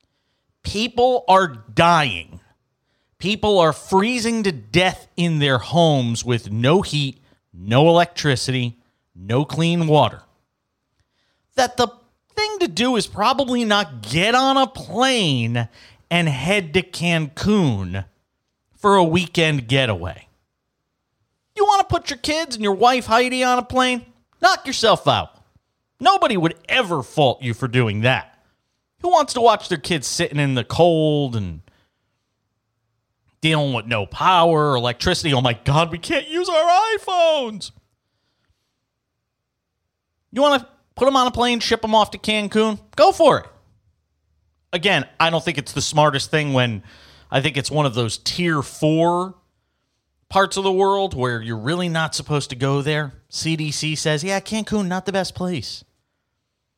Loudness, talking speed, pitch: -19 LUFS, 150 wpm, 155 Hz